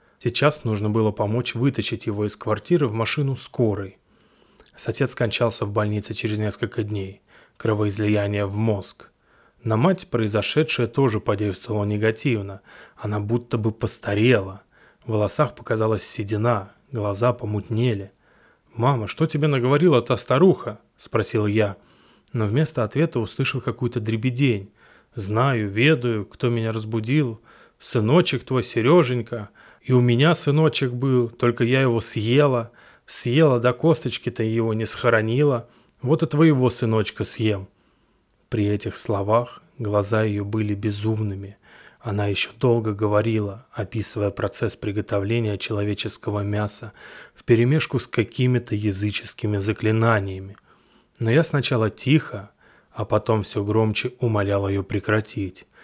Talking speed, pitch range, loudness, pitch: 120 wpm, 105-125 Hz, -22 LUFS, 115 Hz